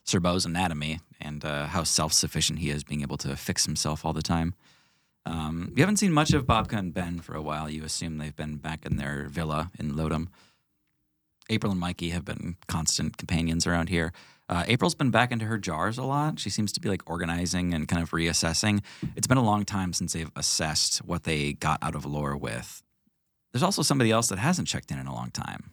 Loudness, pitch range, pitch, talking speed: -27 LUFS, 75-100 Hz, 85 Hz, 220 wpm